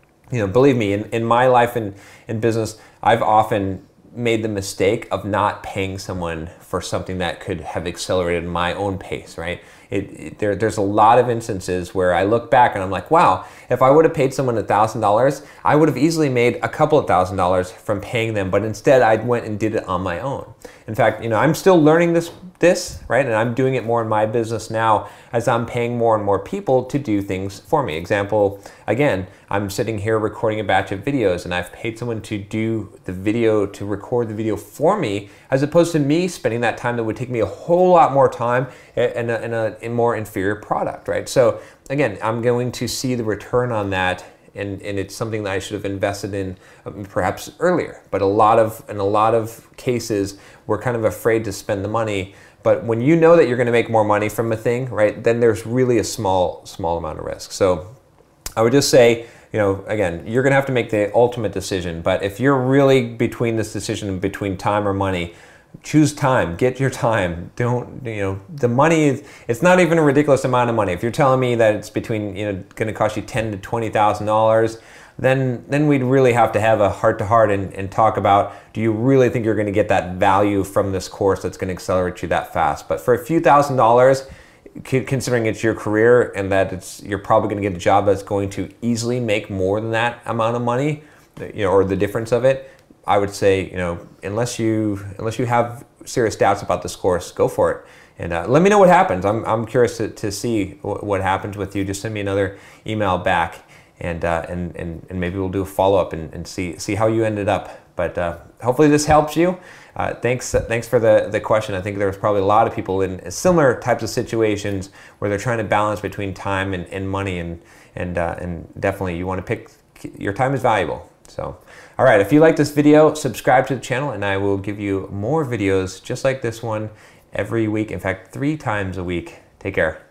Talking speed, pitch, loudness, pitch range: 230 wpm, 110 Hz, -19 LUFS, 100-125 Hz